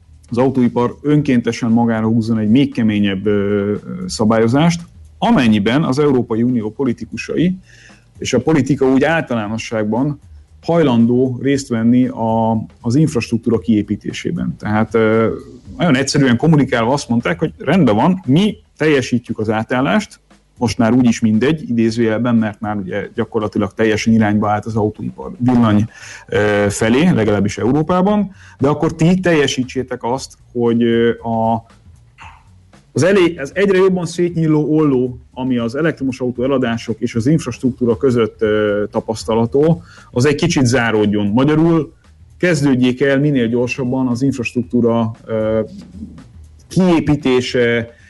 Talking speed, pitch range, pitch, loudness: 110 wpm, 110-135 Hz, 120 Hz, -16 LUFS